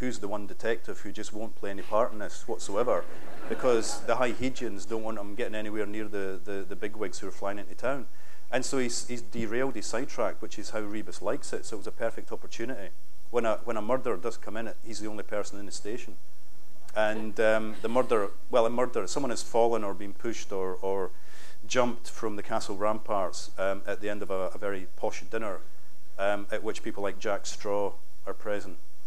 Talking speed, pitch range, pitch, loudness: 220 wpm, 100-115 Hz, 110 Hz, -32 LUFS